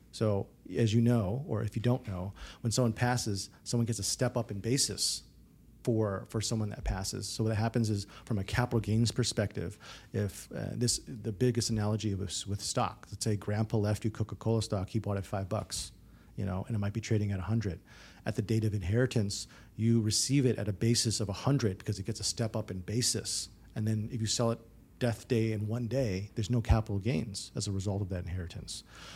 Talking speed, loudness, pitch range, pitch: 220 wpm, -32 LUFS, 100-115 Hz, 110 Hz